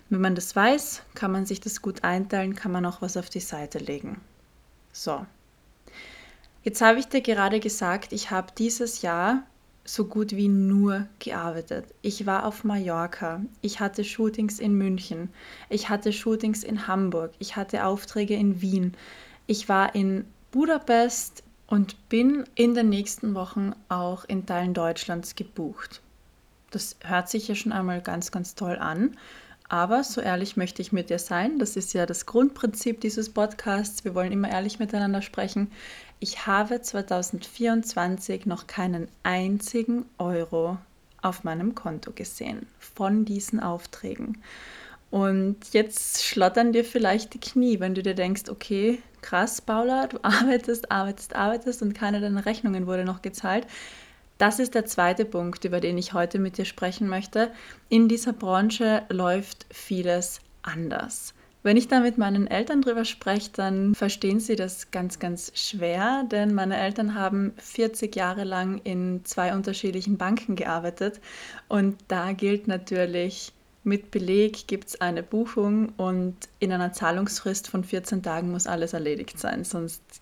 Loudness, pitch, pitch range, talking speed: -26 LUFS, 200 Hz, 185-225 Hz, 155 wpm